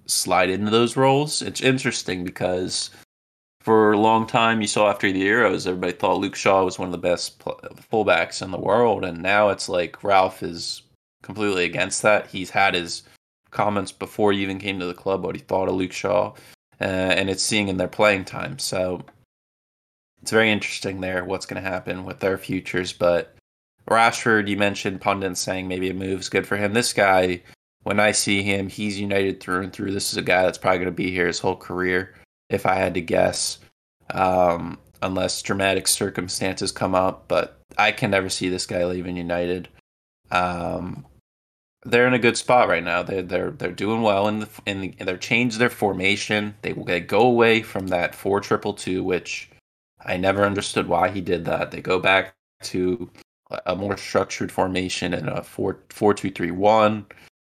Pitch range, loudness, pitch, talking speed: 90-105 Hz, -22 LUFS, 95 Hz, 195 wpm